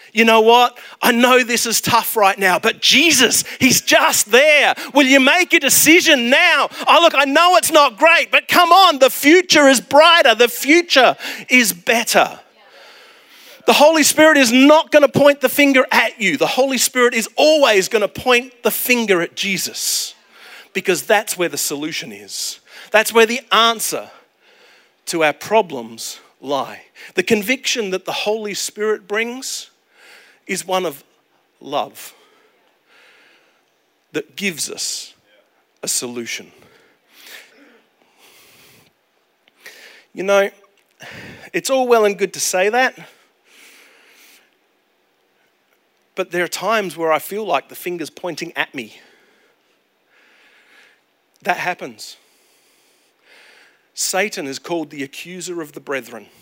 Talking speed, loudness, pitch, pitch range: 135 wpm, -14 LUFS, 235 Hz, 195-290 Hz